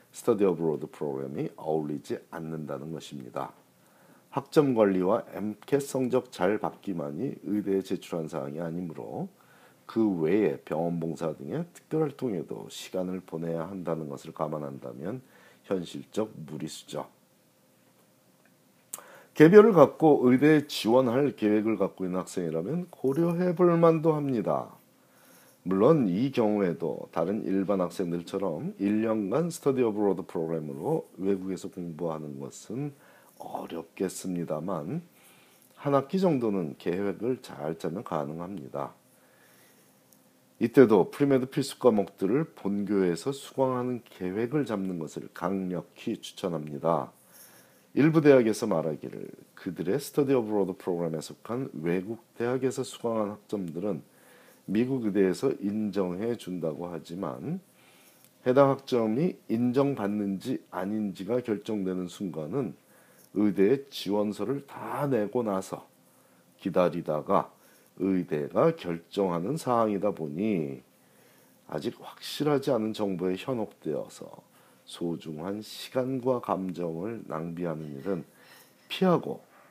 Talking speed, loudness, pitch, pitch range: 275 characters per minute, -28 LUFS, 100 Hz, 85-125 Hz